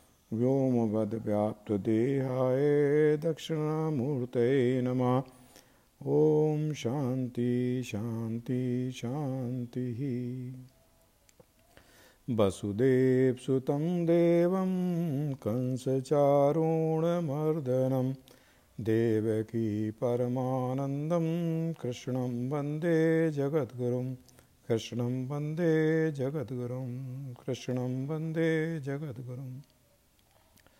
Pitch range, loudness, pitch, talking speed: 125-150 Hz, -30 LUFS, 130 Hz, 40 wpm